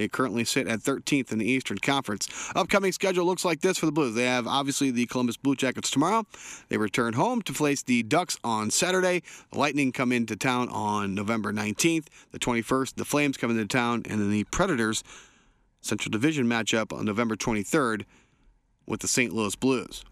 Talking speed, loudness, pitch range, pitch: 190 wpm, -26 LUFS, 110-145 Hz, 125 Hz